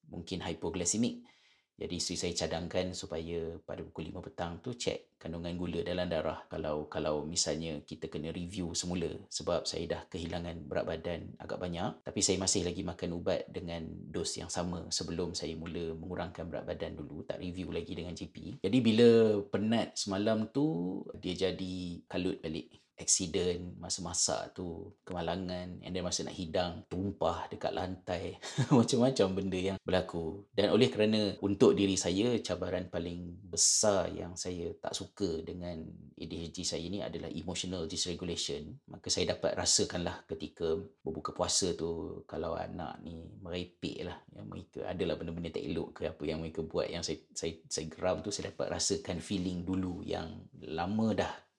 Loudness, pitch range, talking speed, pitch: -34 LUFS, 80-95 Hz, 160 wpm, 90 Hz